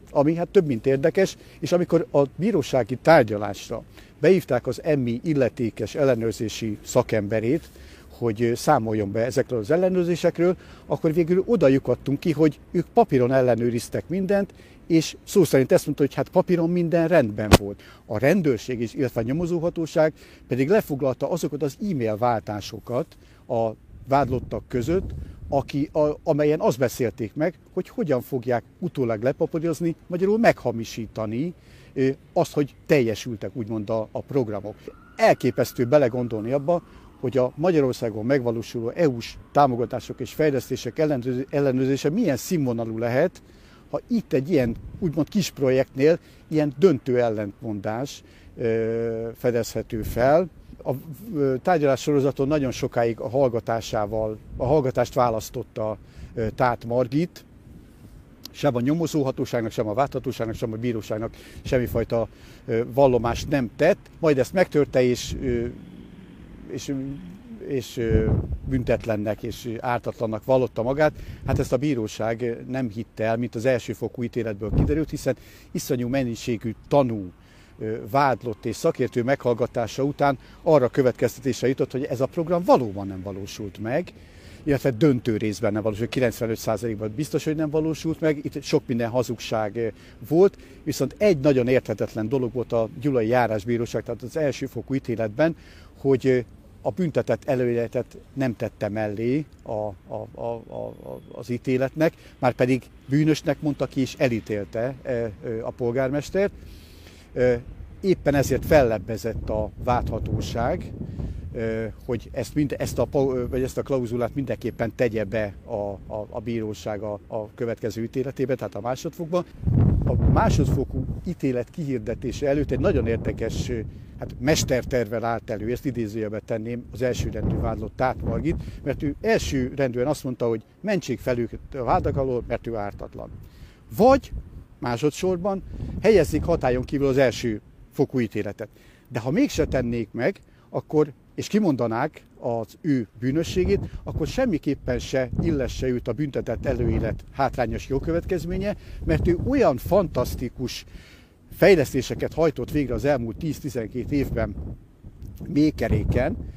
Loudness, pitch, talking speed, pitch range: -24 LUFS, 125 Hz, 125 wpm, 115-145 Hz